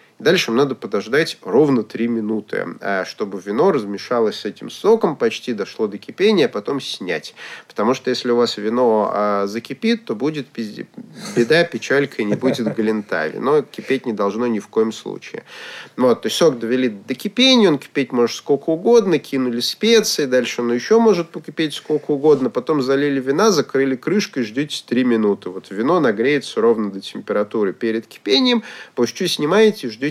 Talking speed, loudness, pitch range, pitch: 170 wpm, -18 LUFS, 115-160 Hz, 130 Hz